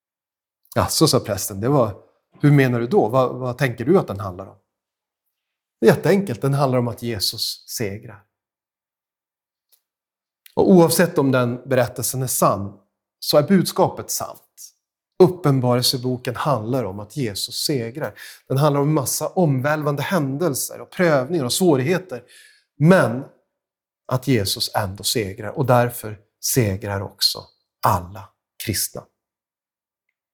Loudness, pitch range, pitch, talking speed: -20 LUFS, 110-150 Hz, 130 Hz, 125 wpm